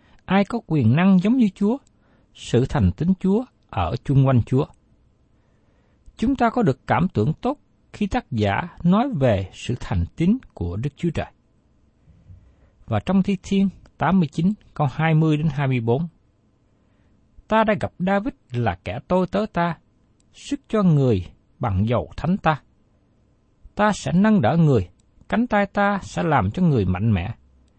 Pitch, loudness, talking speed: 150 Hz, -21 LUFS, 160 wpm